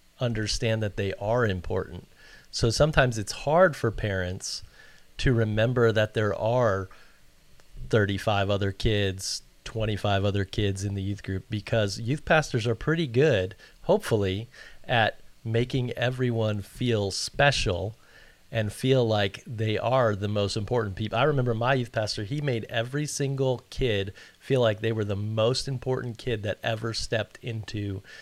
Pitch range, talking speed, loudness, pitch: 100-125 Hz, 145 wpm, -27 LUFS, 110 Hz